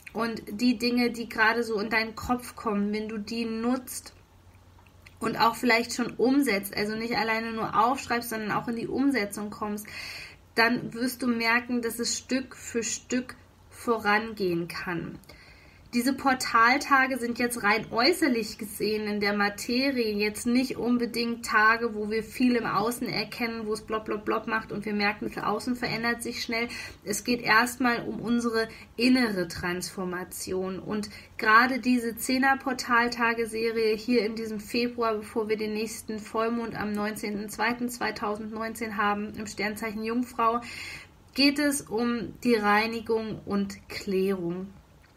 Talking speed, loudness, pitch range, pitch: 140 wpm, -27 LUFS, 210-240 Hz, 225 Hz